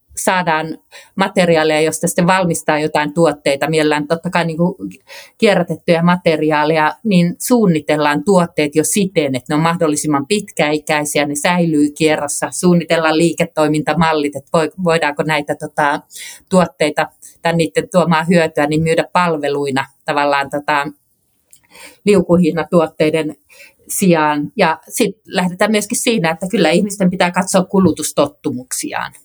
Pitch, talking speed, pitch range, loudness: 160 Hz, 110 wpm, 150-180 Hz, -15 LUFS